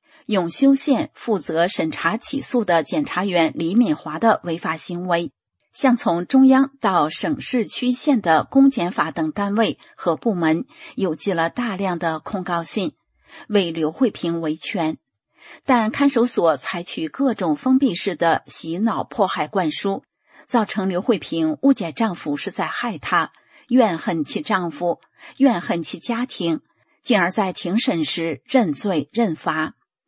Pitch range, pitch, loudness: 170-260 Hz, 210 Hz, -21 LUFS